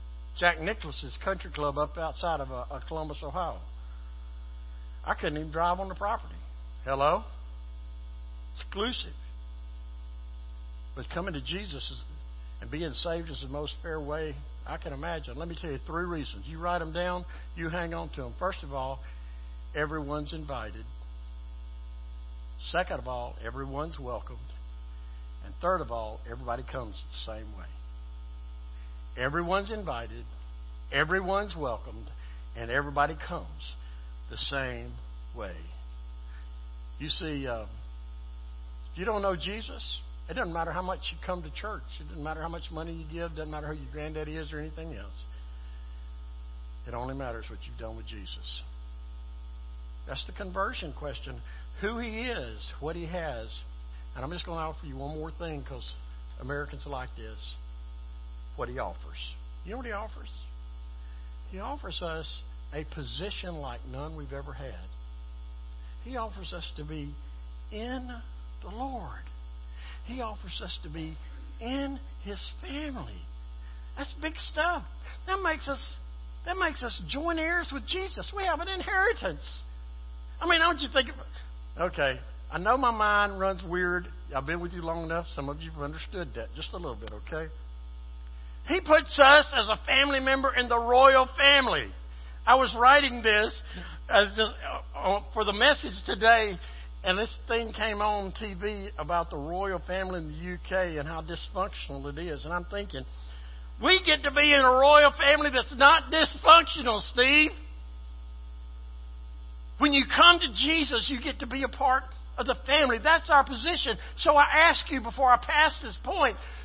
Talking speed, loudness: 160 wpm, -27 LUFS